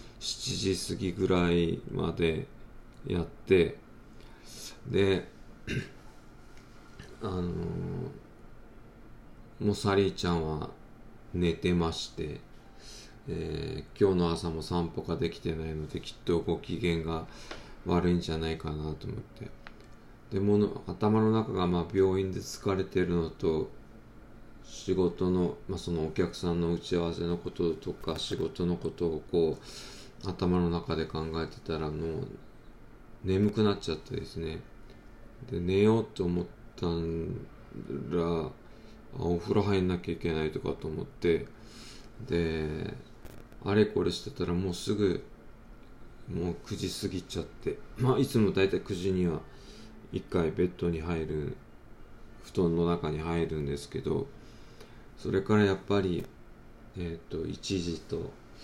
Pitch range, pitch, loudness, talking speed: 85-100 Hz, 90 Hz, -31 LUFS, 230 characters per minute